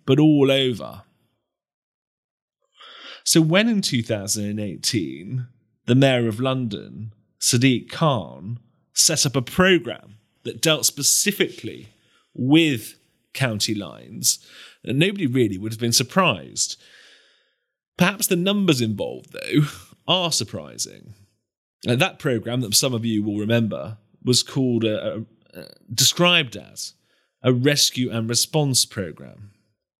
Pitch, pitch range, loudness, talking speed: 125 Hz, 110-145 Hz, -20 LUFS, 115 wpm